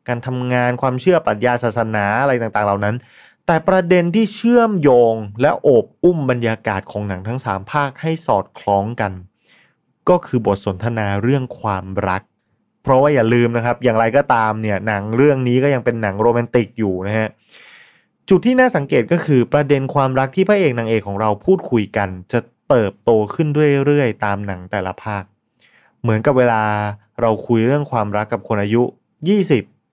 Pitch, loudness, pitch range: 120 Hz, -17 LUFS, 105-140 Hz